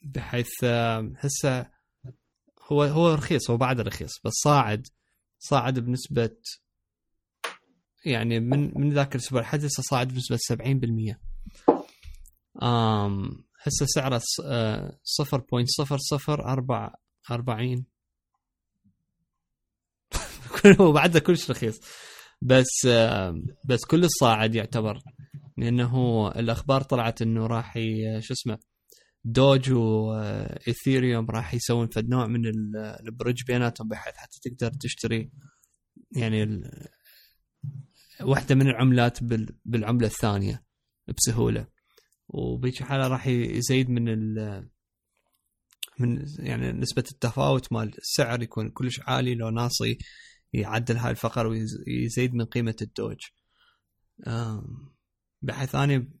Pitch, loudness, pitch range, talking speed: 120 Hz, -25 LUFS, 115-135 Hz, 100 wpm